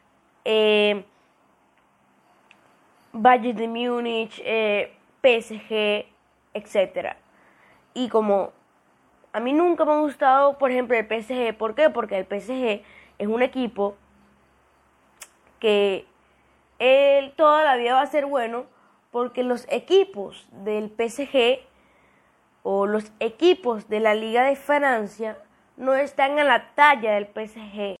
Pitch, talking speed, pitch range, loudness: 230 Hz, 120 wpm, 210-270 Hz, -22 LUFS